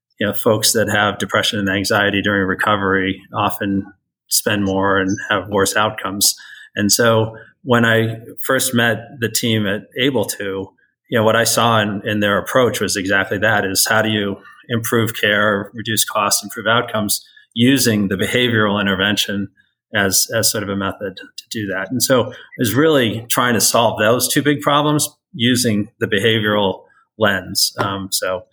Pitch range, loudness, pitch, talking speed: 100-115 Hz, -16 LUFS, 105 Hz, 170 wpm